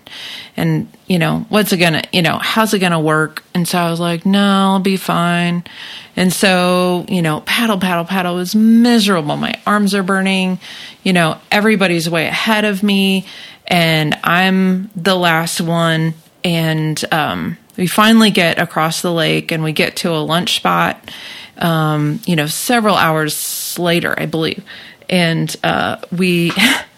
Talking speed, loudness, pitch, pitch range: 160 wpm, -14 LUFS, 180 Hz, 165-195 Hz